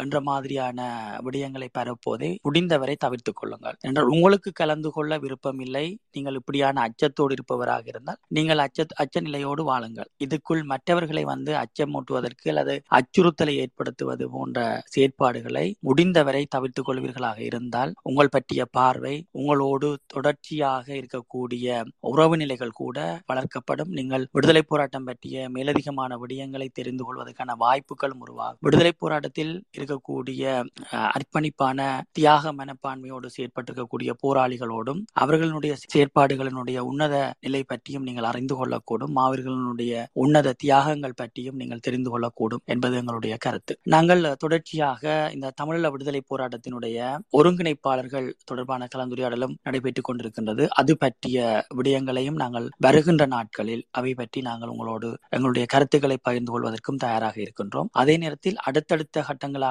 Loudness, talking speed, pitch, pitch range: -25 LUFS, 105 wpm, 135 Hz, 125-150 Hz